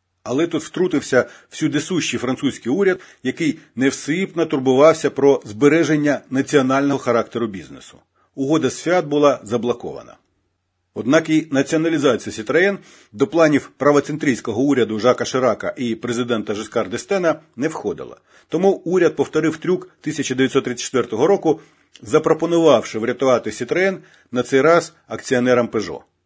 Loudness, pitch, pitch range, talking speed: -19 LUFS, 140 Hz, 120-160 Hz, 110 wpm